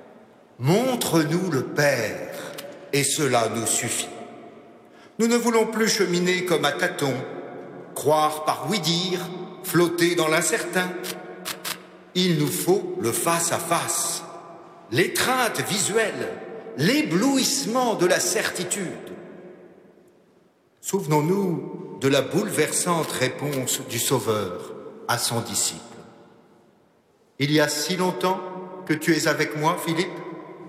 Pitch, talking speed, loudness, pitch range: 170 Hz, 105 wpm, -23 LUFS, 150-185 Hz